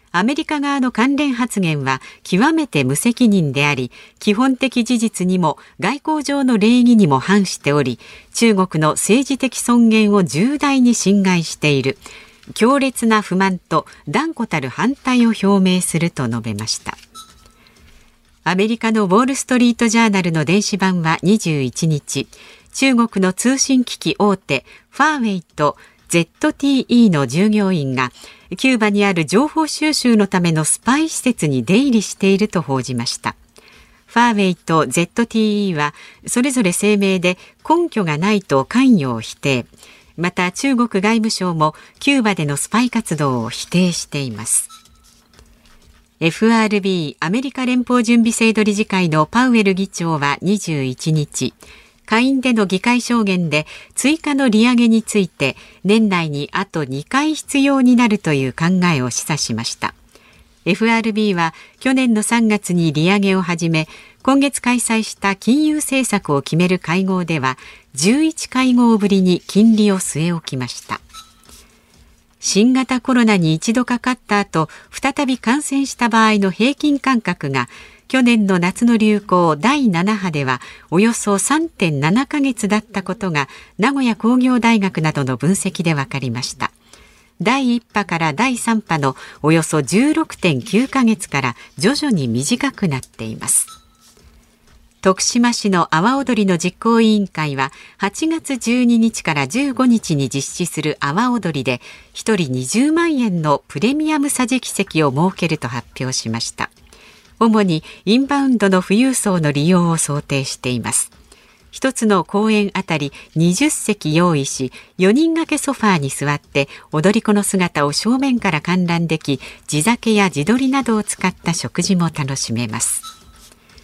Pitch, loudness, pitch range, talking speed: 200 Hz, -16 LUFS, 160-240 Hz, 270 characters per minute